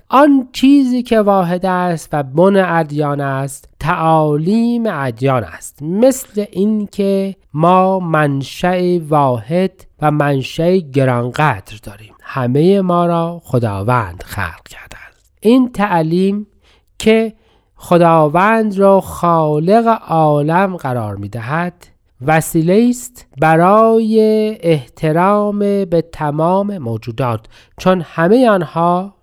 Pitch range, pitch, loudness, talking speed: 140-200 Hz, 170 Hz, -14 LUFS, 95 wpm